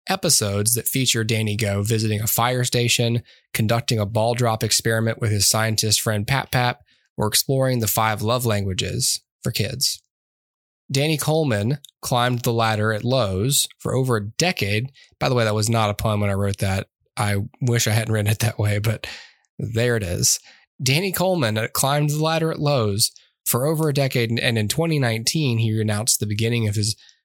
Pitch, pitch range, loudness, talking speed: 115 Hz, 110-130 Hz, -21 LUFS, 185 wpm